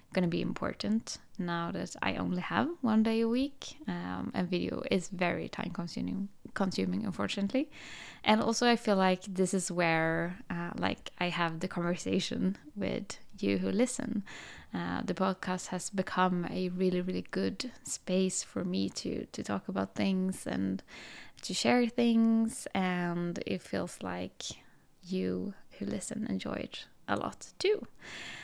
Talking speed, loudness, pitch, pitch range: 155 wpm, -33 LUFS, 185 Hz, 175-215 Hz